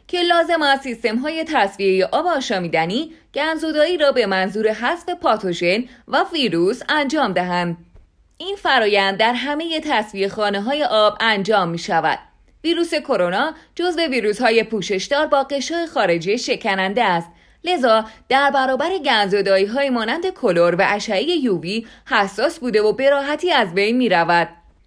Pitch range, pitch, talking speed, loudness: 200-300 Hz, 240 Hz, 145 wpm, -18 LUFS